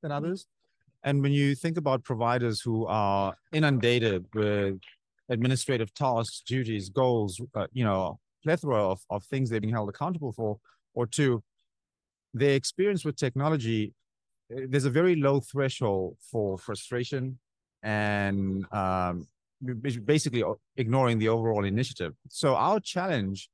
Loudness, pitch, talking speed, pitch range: -28 LUFS, 120 Hz, 135 wpm, 105-135 Hz